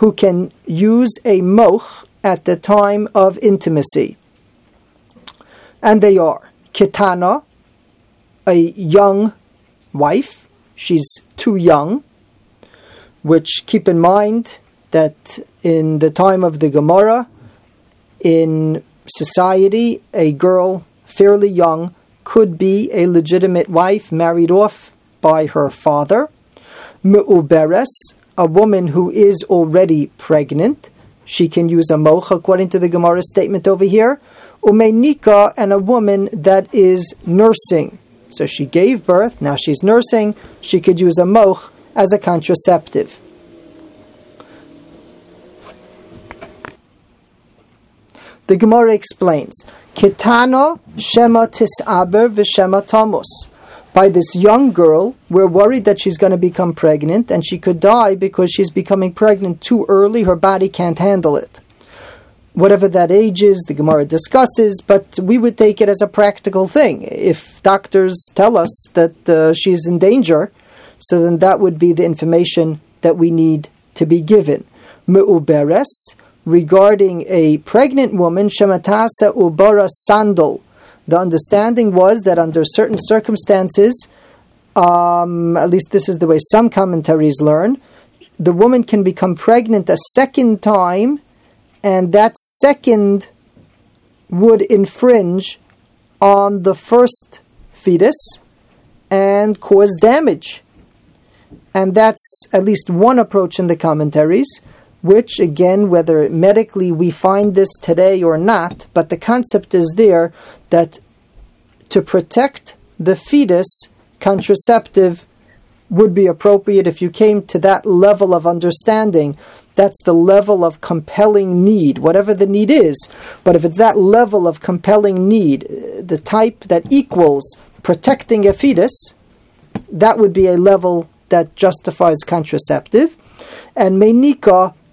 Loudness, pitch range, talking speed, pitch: -12 LUFS, 170-210 Hz, 125 wpm, 190 Hz